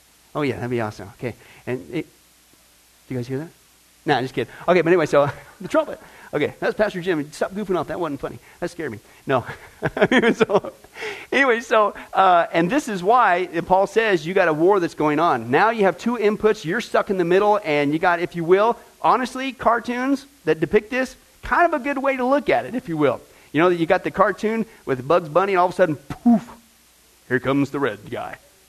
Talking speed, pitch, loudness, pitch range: 225 wpm, 180 Hz, -20 LUFS, 145-225 Hz